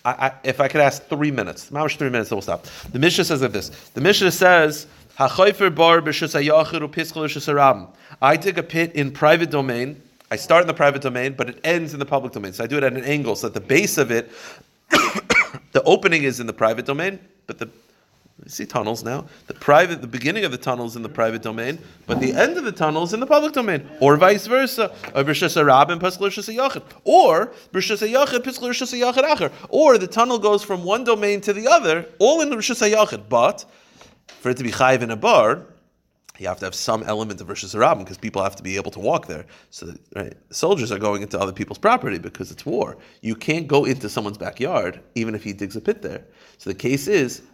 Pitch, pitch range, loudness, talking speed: 150 Hz, 125-190 Hz, -19 LUFS, 205 wpm